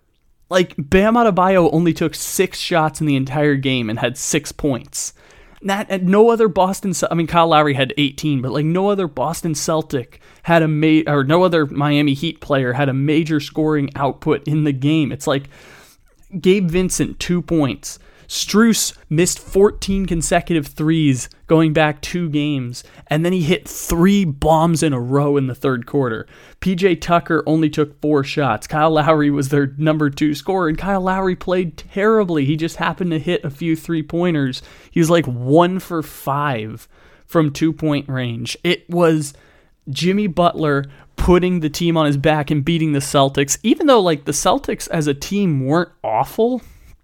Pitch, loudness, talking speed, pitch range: 155 Hz, -17 LUFS, 175 wpm, 145-175 Hz